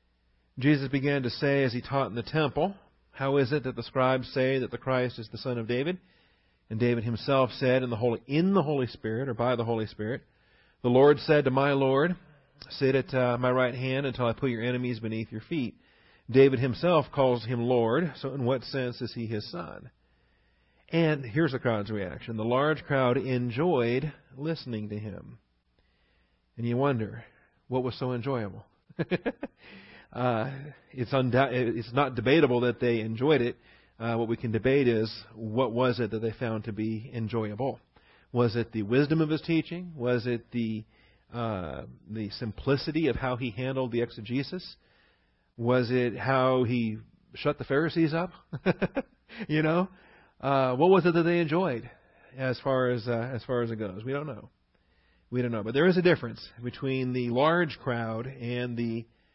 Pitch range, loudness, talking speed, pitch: 115-140 Hz, -28 LUFS, 180 wpm, 125 Hz